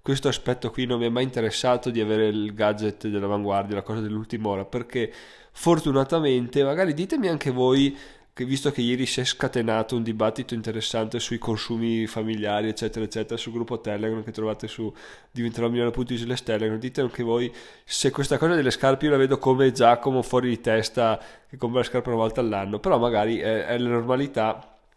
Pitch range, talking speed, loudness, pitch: 110-130 Hz, 185 wpm, -25 LUFS, 120 Hz